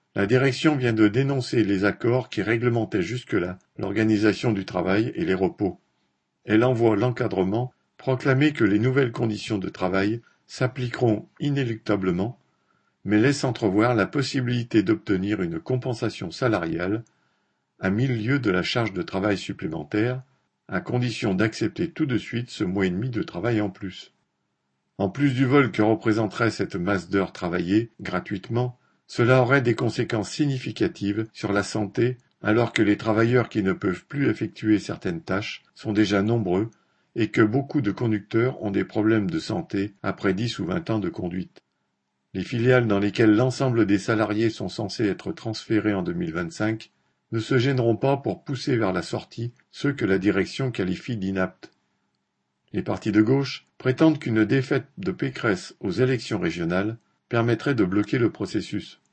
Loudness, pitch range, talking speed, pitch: -24 LUFS, 105-130 Hz, 160 wpm, 110 Hz